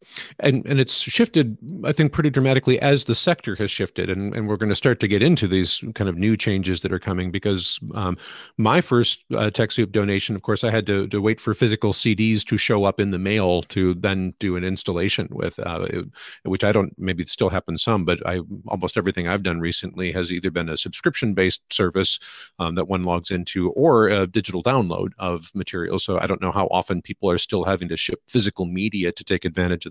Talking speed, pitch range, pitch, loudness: 220 wpm, 90-110 Hz, 100 Hz, -21 LUFS